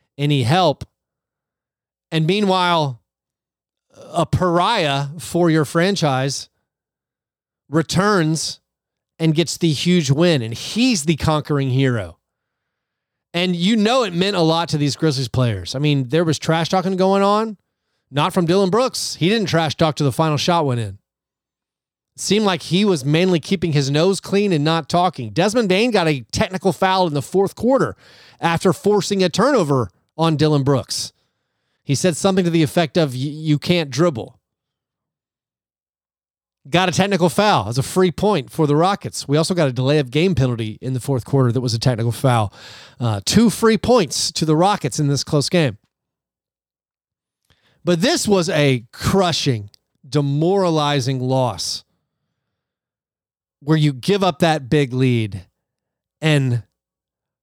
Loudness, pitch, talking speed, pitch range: -18 LUFS, 160 Hz, 155 wpm, 135-185 Hz